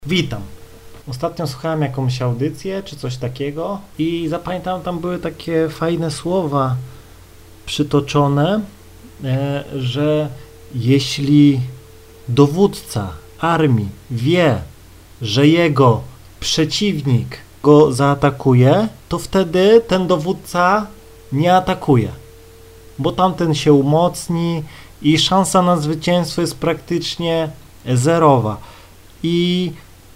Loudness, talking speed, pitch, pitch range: -17 LUFS, 90 wpm, 145 Hz, 120-170 Hz